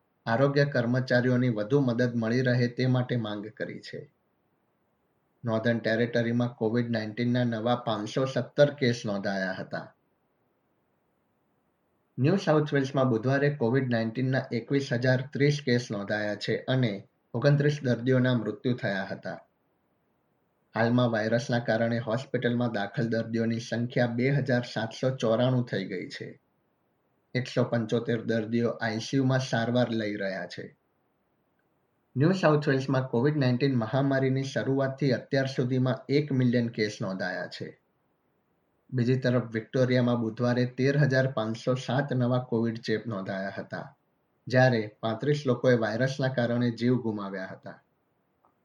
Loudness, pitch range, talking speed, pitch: -28 LUFS, 115-130 Hz, 120 wpm, 120 Hz